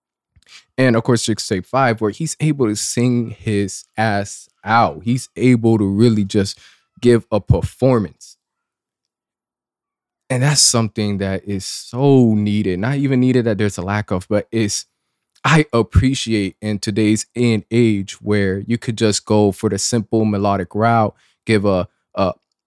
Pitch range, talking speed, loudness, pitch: 100-120 Hz, 155 wpm, -17 LUFS, 110 Hz